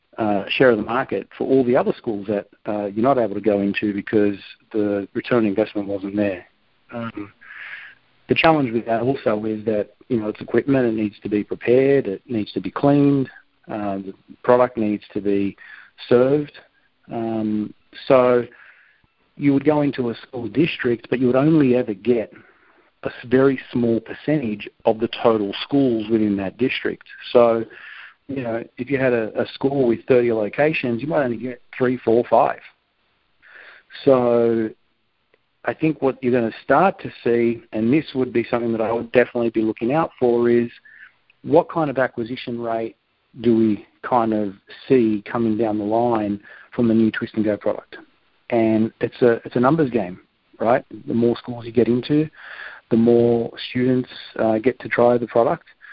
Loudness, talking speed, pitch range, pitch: -20 LUFS, 180 wpm, 110-125 Hz, 115 Hz